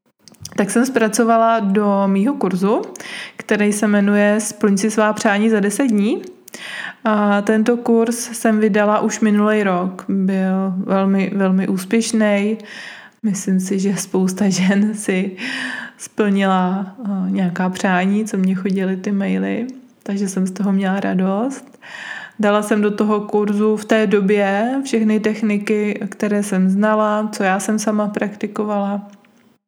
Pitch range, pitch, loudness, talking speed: 195-220 Hz, 210 Hz, -17 LUFS, 135 wpm